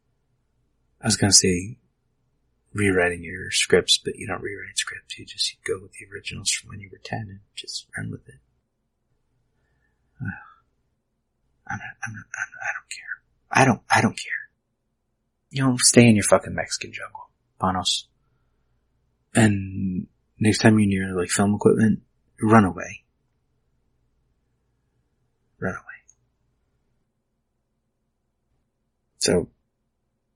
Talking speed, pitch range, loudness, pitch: 130 wpm, 100-125 Hz, -21 LUFS, 115 Hz